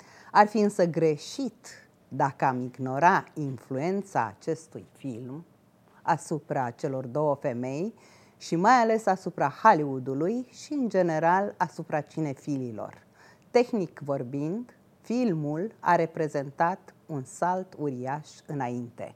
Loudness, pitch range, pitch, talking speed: -28 LUFS, 140-185 Hz, 160 Hz, 105 wpm